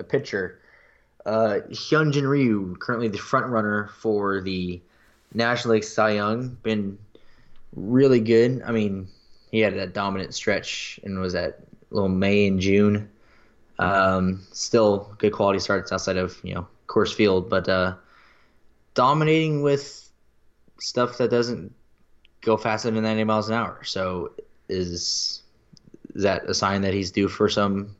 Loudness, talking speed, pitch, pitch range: -23 LUFS, 145 wpm, 105 Hz, 95-115 Hz